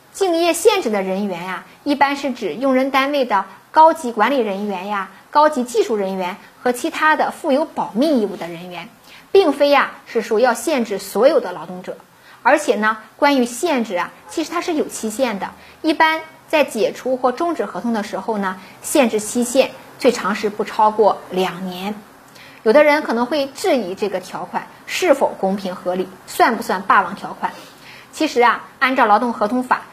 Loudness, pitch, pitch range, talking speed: -18 LUFS, 240 Hz, 195-290 Hz, 275 characters per minute